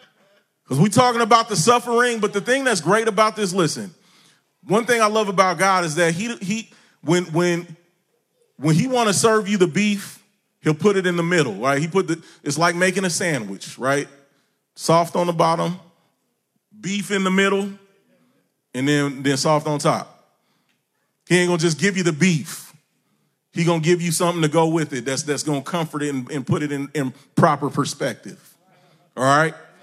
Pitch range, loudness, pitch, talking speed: 155-200 Hz, -20 LUFS, 175 Hz, 200 wpm